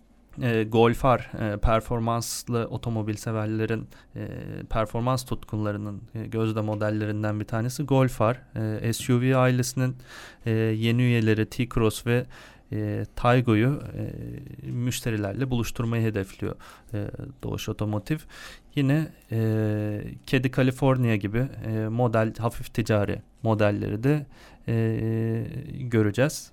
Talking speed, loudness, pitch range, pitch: 100 wpm, -26 LUFS, 110-130 Hz, 115 Hz